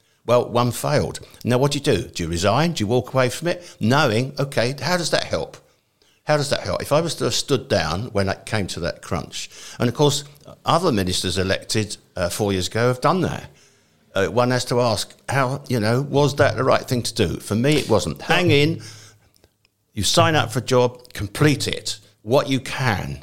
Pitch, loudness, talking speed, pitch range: 120 Hz, -21 LUFS, 220 wpm, 105-140 Hz